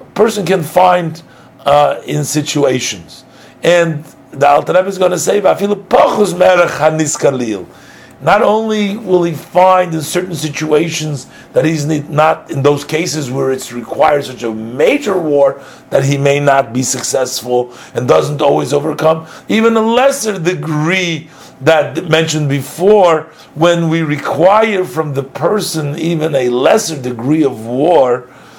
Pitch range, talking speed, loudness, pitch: 140-180 Hz, 135 wpm, -13 LUFS, 155 Hz